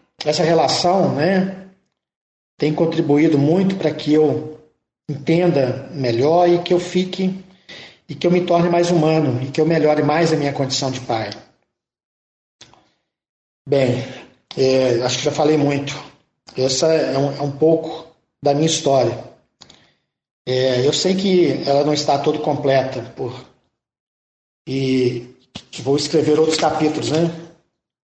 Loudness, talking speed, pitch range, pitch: -18 LUFS, 135 wpm, 135-165 Hz, 150 Hz